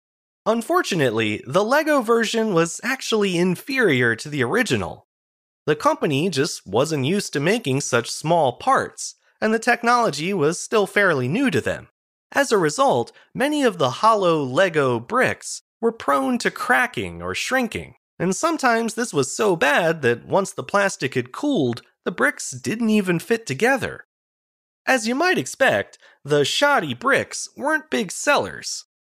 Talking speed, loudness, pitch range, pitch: 150 wpm, -21 LUFS, 145-240 Hz, 200 Hz